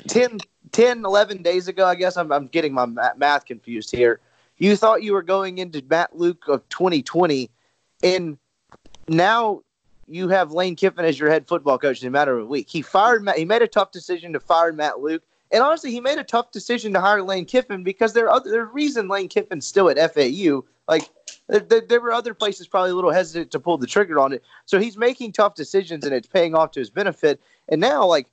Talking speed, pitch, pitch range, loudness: 230 wpm, 185 Hz, 160-220 Hz, -20 LUFS